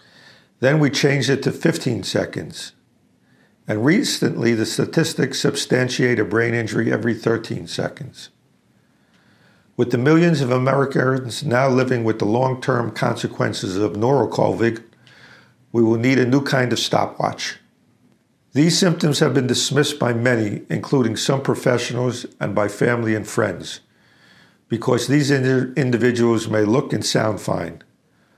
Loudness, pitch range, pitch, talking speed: -19 LUFS, 115-140 Hz, 125 Hz, 135 wpm